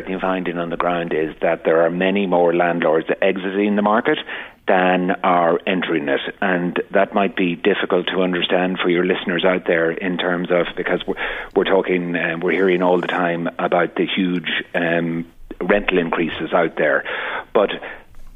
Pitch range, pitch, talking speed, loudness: 85-95 Hz, 90 Hz, 175 wpm, -19 LUFS